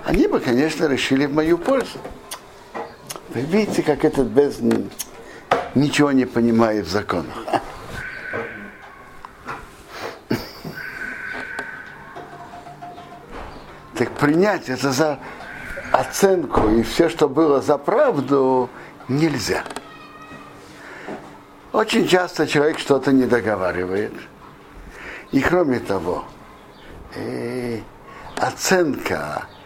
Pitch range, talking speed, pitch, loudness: 125-175 Hz, 80 wpm, 145 Hz, -20 LUFS